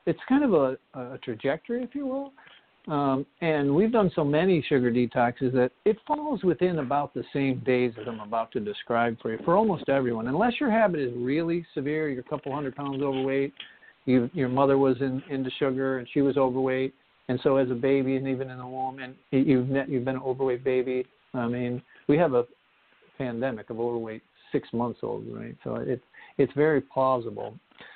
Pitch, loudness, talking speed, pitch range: 135 Hz, -27 LUFS, 200 wpm, 125-150 Hz